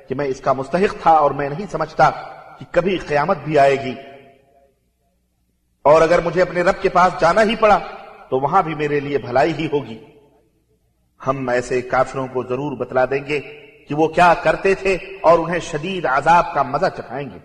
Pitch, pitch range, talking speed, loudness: 145 Hz, 130-175 Hz, 190 wpm, -18 LUFS